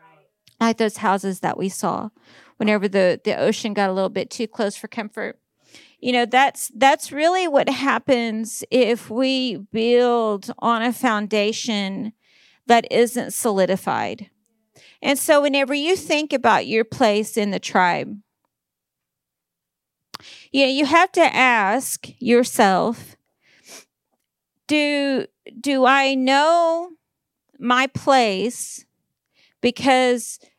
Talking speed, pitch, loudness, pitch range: 115 wpm, 240 Hz, -19 LUFS, 215-270 Hz